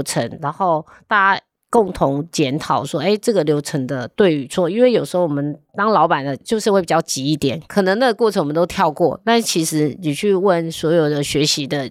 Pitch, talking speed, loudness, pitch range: 165 Hz, 305 characters per minute, -18 LUFS, 145-195 Hz